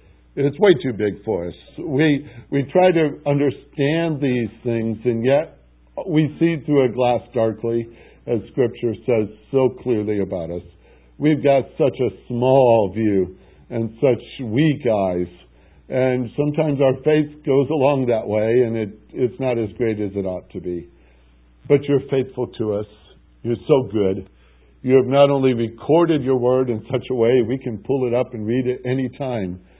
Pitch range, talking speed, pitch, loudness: 105-135 Hz, 175 wpm, 125 Hz, -20 LUFS